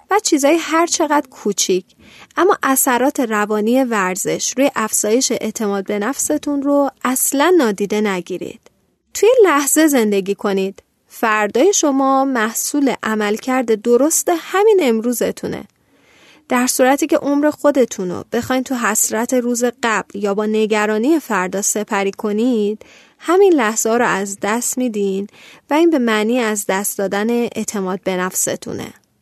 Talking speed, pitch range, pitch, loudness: 130 wpm, 210-280 Hz, 235 Hz, -16 LUFS